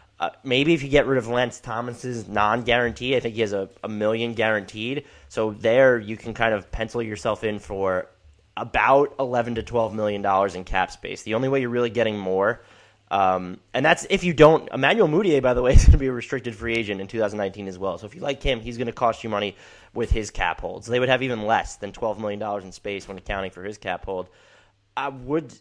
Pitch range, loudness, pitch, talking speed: 100-125 Hz, -23 LUFS, 115 Hz, 235 wpm